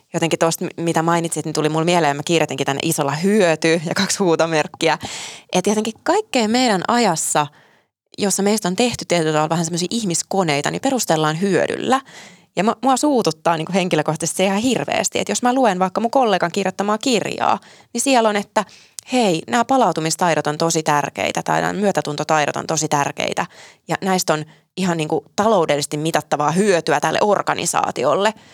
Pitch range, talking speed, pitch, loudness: 155-210 Hz, 160 wpm, 175 Hz, -18 LUFS